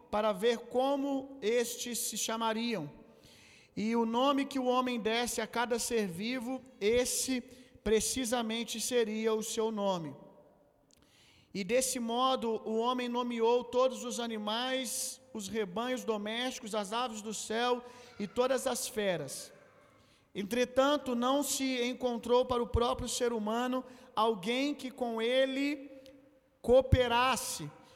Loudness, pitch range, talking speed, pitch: -32 LUFS, 225-255 Hz, 120 wpm, 240 Hz